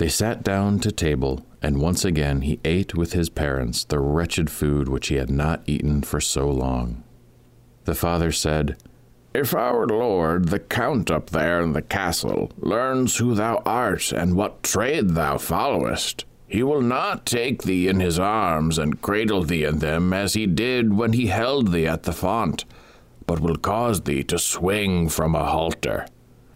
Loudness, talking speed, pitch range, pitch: -22 LUFS, 175 wpm, 75-100 Hz, 85 Hz